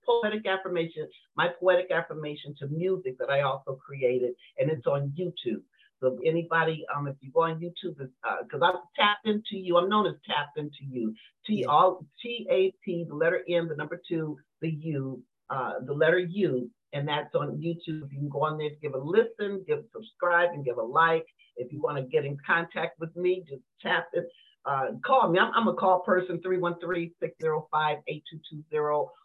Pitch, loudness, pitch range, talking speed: 165 Hz, -28 LUFS, 150-185 Hz, 190 wpm